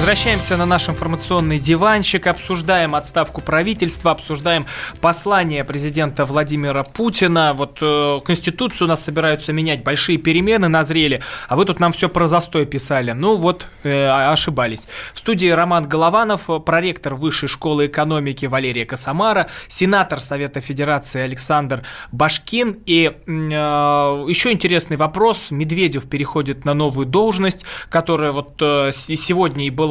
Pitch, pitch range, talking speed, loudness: 155 Hz, 145-175 Hz, 130 wpm, -17 LUFS